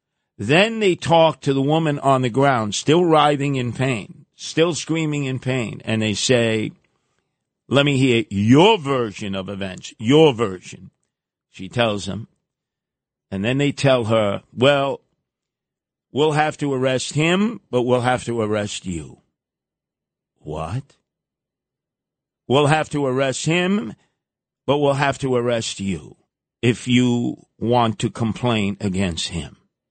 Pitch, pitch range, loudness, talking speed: 130 Hz, 110-145 Hz, -19 LUFS, 135 wpm